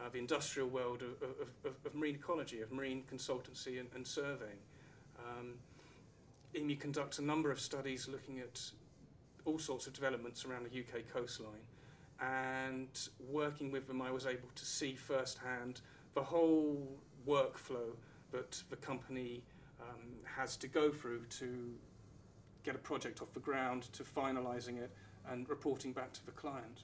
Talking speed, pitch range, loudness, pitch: 155 wpm, 125-140 Hz, -43 LUFS, 130 Hz